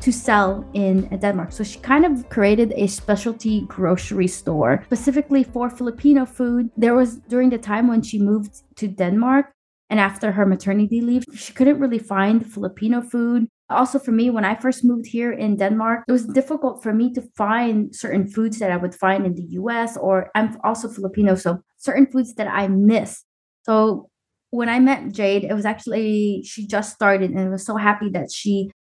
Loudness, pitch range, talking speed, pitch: -20 LUFS, 200-240 Hz, 190 wpm, 220 Hz